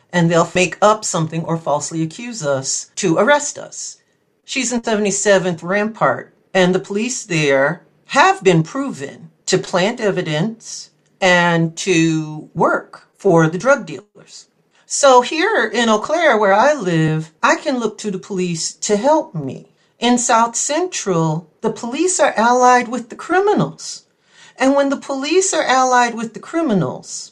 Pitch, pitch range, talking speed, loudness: 205 Hz, 170-250 Hz, 150 wpm, -16 LUFS